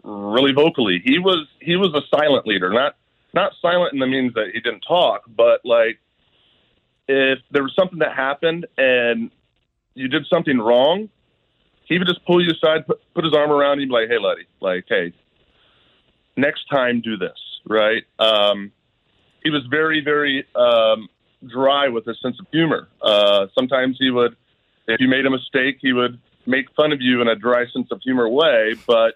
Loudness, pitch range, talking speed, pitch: -18 LUFS, 120-155 Hz, 185 wpm, 135 Hz